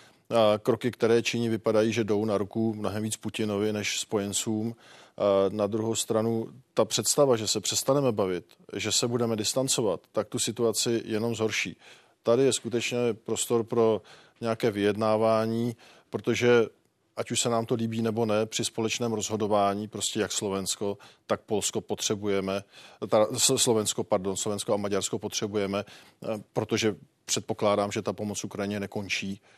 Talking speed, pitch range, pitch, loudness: 145 wpm, 105-115 Hz, 110 Hz, -27 LUFS